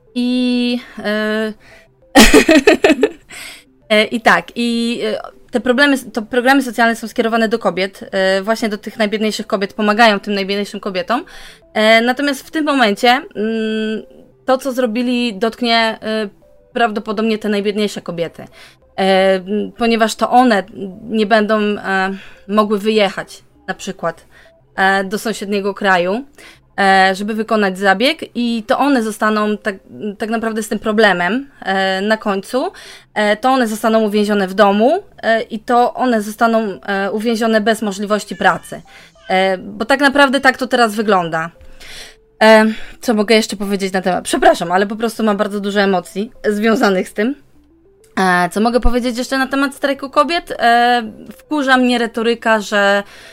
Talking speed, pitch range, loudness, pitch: 135 wpm, 200-240 Hz, -15 LUFS, 220 Hz